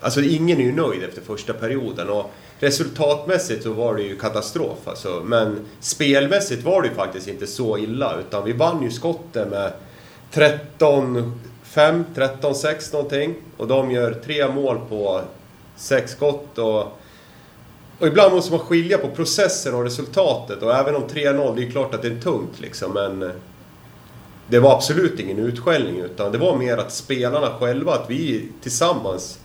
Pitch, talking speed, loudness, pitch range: 135 Hz, 165 wpm, -20 LUFS, 115-150 Hz